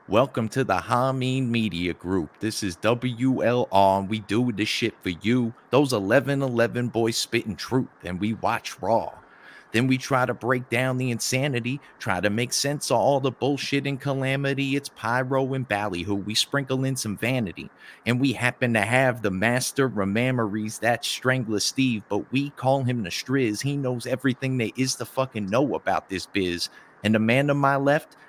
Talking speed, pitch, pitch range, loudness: 185 wpm, 125 Hz, 110-130 Hz, -24 LUFS